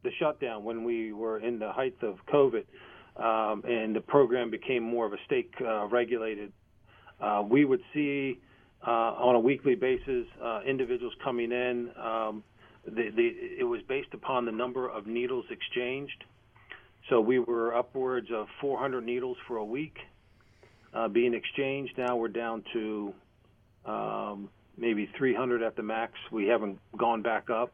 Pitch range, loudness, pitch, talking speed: 110-135 Hz, -31 LUFS, 120 Hz, 160 wpm